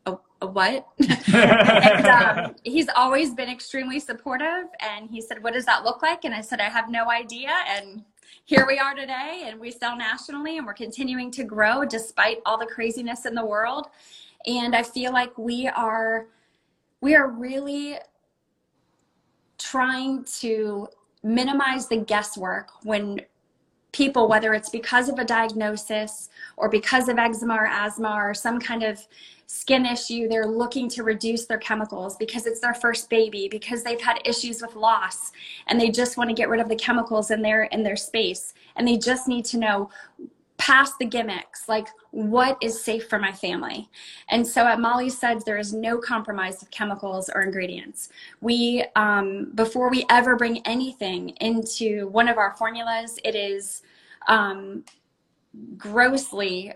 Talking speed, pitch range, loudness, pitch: 165 wpm, 215-250 Hz, -23 LUFS, 230 Hz